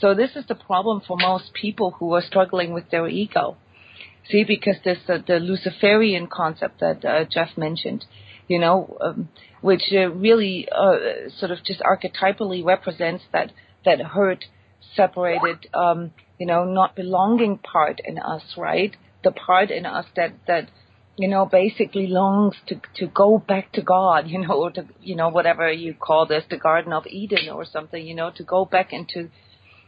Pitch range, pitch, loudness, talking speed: 165-195 Hz, 185 Hz, -21 LUFS, 175 wpm